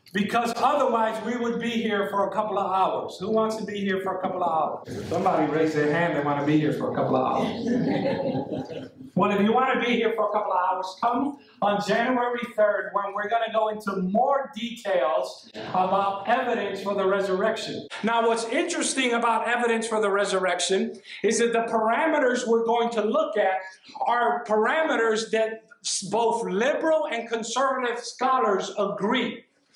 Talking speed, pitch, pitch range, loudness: 180 wpm, 220 Hz, 200-235 Hz, -25 LUFS